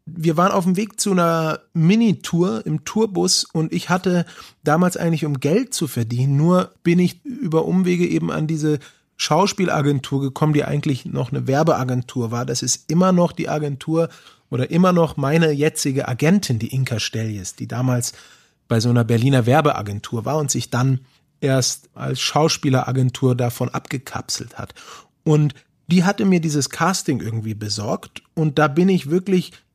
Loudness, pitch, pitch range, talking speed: -20 LUFS, 150 Hz, 130-175 Hz, 160 wpm